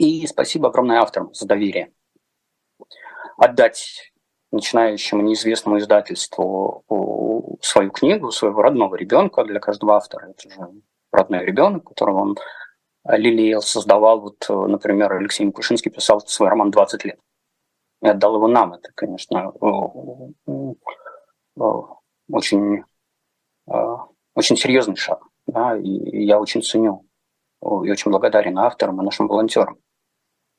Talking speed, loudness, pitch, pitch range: 110 wpm, -18 LUFS, 105 Hz, 105-110 Hz